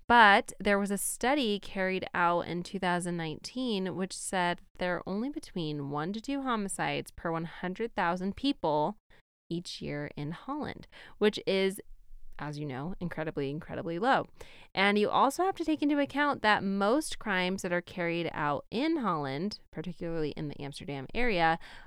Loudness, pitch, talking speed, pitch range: -31 LUFS, 185 Hz, 155 wpm, 165-215 Hz